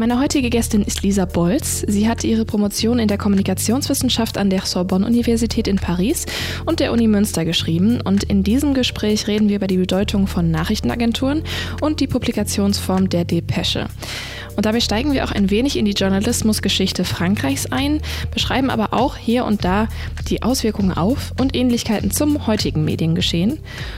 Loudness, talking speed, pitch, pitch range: -18 LUFS, 165 wpm, 205 Hz, 165-235 Hz